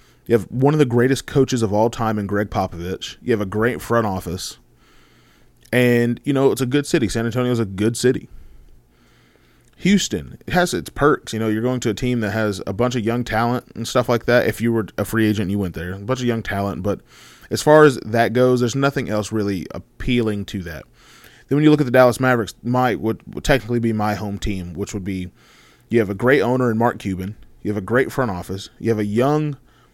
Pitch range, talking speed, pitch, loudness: 100-125 Hz, 240 wpm, 115 Hz, -20 LUFS